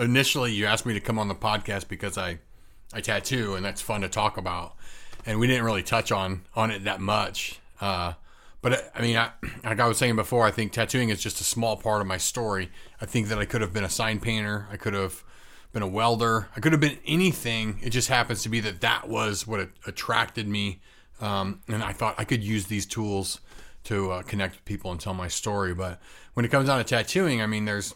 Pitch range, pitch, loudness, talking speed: 100-115 Hz, 110 Hz, -27 LUFS, 240 wpm